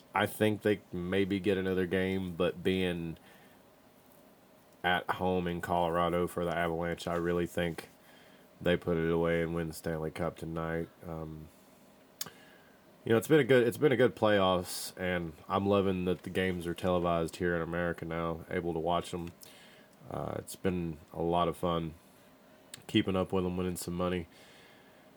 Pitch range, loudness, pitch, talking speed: 85-95 Hz, -32 LUFS, 90 Hz, 170 wpm